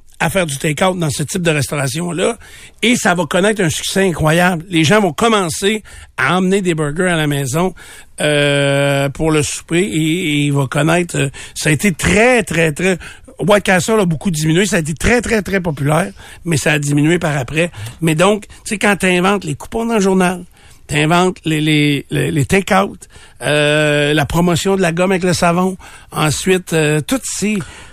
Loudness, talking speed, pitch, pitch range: -15 LUFS, 195 wpm, 170 Hz, 150-190 Hz